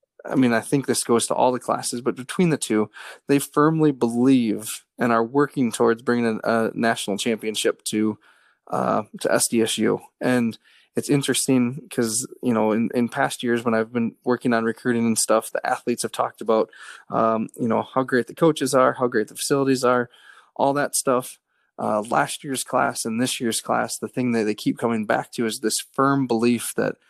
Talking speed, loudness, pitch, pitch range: 200 wpm, -22 LUFS, 120 Hz, 115-130 Hz